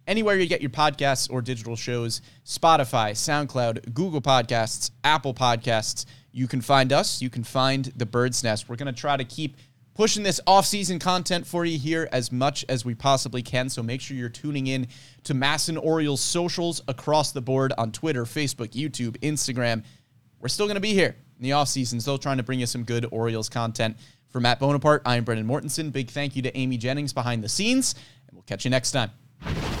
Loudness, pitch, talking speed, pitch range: -25 LUFS, 130 Hz, 200 wpm, 120-150 Hz